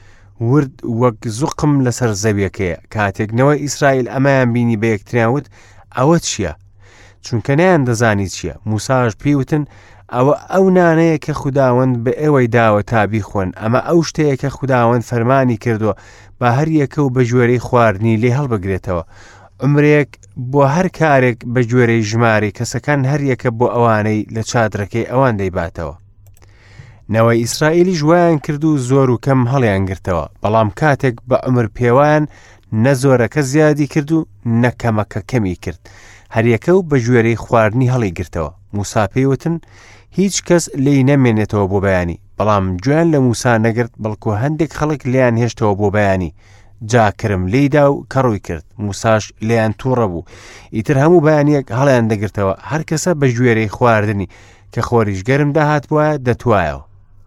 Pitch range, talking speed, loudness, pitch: 105-140 Hz, 135 wpm, -15 LUFS, 120 Hz